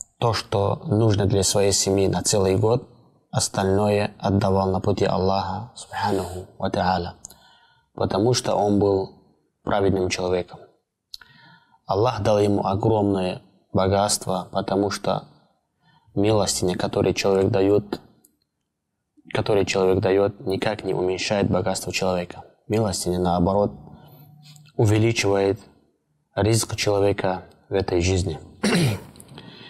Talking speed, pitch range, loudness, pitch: 90 wpm, 95-105 Hz, -22 LUFS, 95 Hz